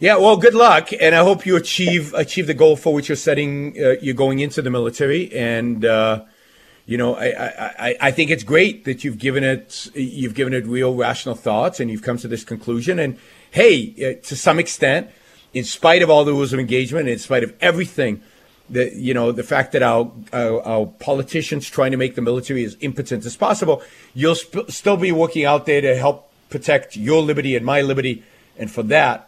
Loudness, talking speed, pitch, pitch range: -18 LUFS, 210 wpm, 135 Hz, 125-160 Hz